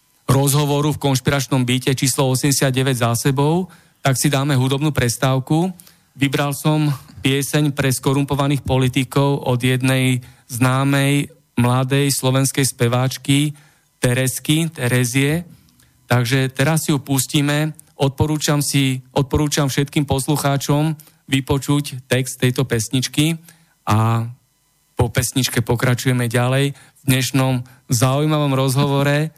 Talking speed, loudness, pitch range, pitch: 100 wpm, -18 LUFS, 130-145 Hz, 140 Hz